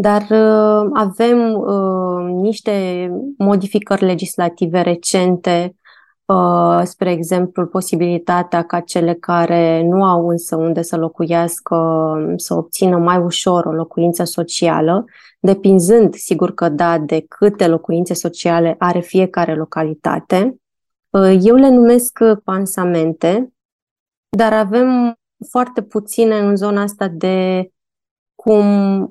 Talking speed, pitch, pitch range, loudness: 110 wpm, 185 Hz, 170-210 Hz, -15 LUFS